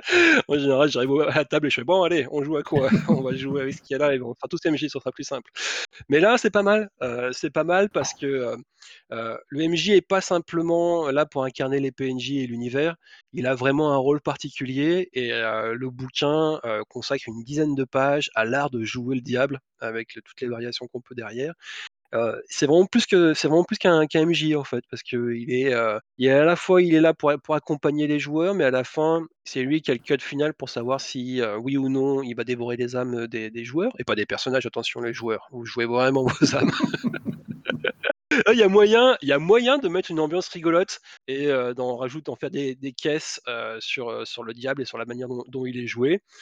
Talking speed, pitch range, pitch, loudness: 245 wpm, 125-160 Hz, 140 Hz, -23 LUFS